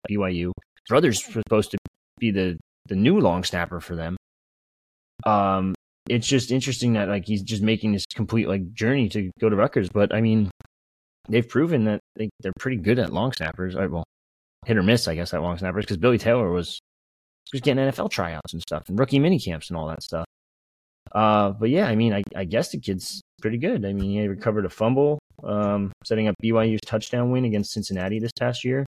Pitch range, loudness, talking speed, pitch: 90-115 Hz, -24 LUFS, 205 wpm, 105 Hz